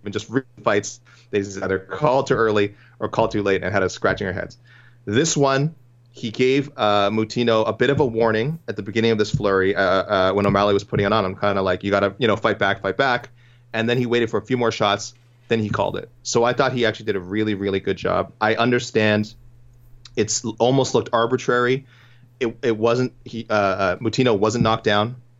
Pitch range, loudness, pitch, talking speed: 105-120 Hz, -21 LUFS, 115 Hz, 225 wpm